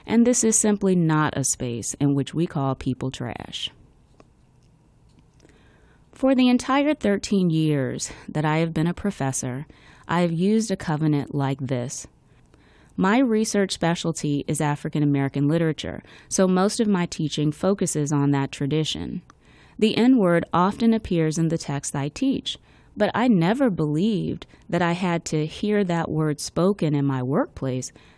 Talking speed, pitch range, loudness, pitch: 155 wpm, 145-200 Hz, -23 LUFS, 165 Hz